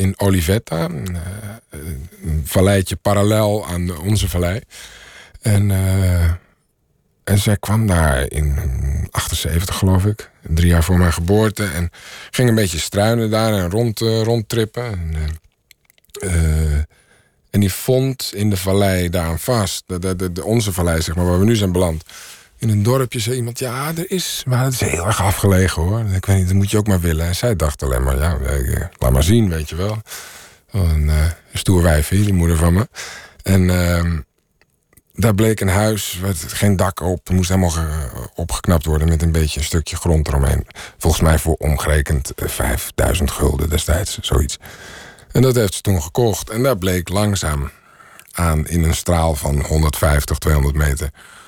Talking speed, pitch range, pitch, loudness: 175 wpm, 80-105 Hz, 90 Hz, -18 LUFS